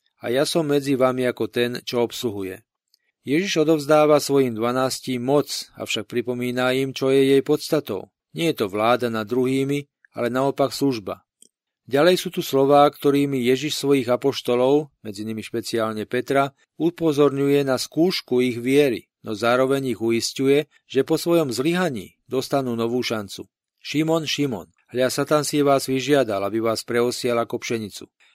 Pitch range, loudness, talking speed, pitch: 120-145 Hz, -21 LUFS, 150 wpm, 135 Hz